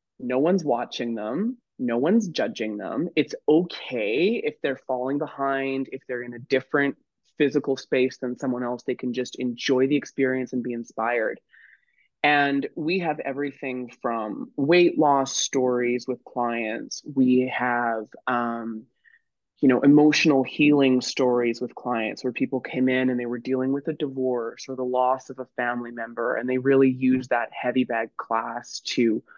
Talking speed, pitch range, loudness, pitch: 165 wpm, 125-140 Hz, -24 LUFS, 130 Hz